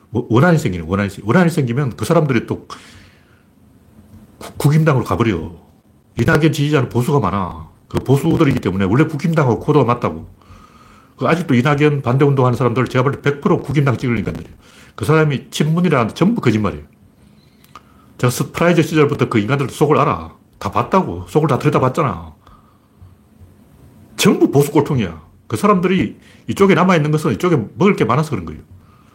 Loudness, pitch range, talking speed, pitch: -16 LUFS, 105-155 Hz, 350 characters per minute, 125 Hz